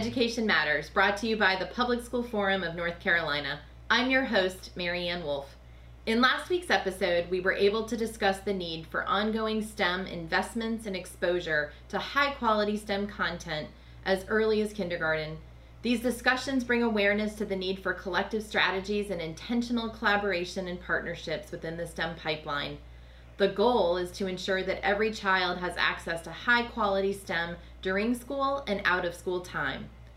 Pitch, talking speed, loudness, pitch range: 190 Hz, 165 wpm, -29 LUFS, 170-215 Hz